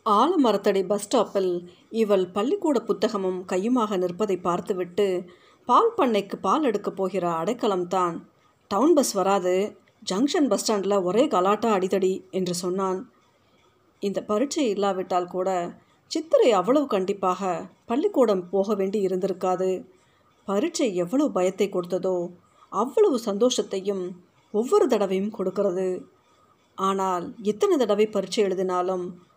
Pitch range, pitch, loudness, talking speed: 185-215 Hz, 195 Hz, -24 LUFS, 105 wpm